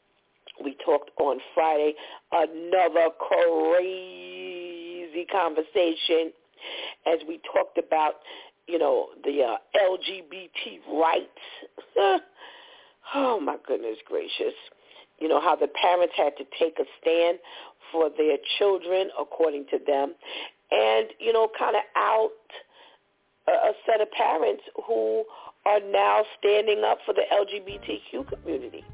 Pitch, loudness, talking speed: 205 Hz, -25 LUFS, 120 wpm